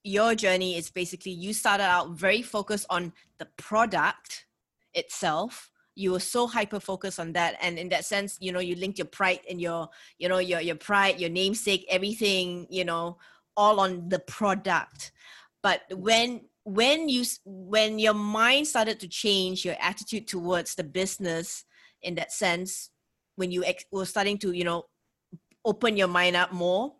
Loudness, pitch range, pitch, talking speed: -27 LUFS, 180-210 Hz, 190 Hz, 170 wpm